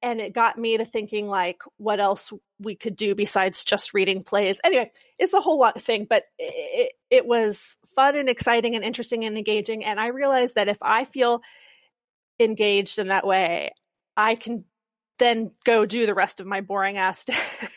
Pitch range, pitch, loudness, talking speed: 205-240 Hz, 220 Hz, -22 LUFS, 190 wpm